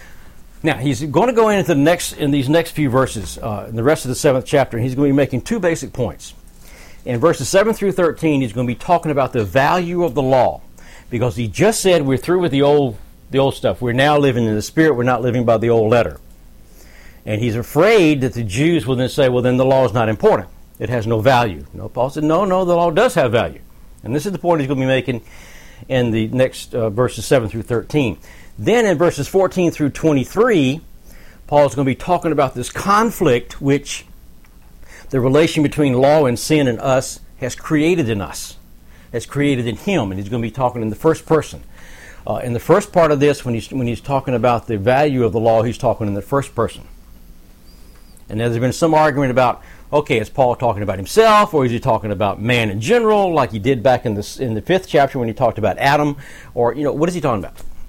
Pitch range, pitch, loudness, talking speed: 110-150 Hz, 130 Hz, -17 LUFS, 235 wpm